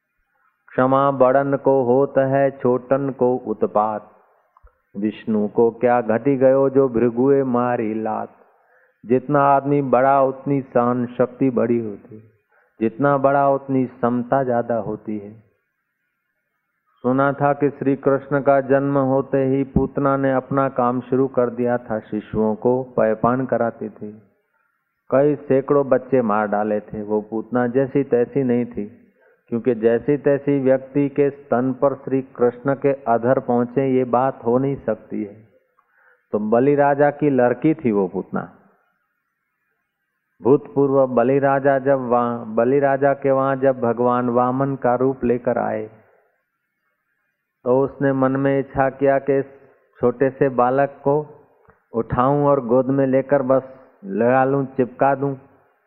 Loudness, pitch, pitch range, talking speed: -19 LUFS, 130 Hz, 120-140 Hz, 135 wpm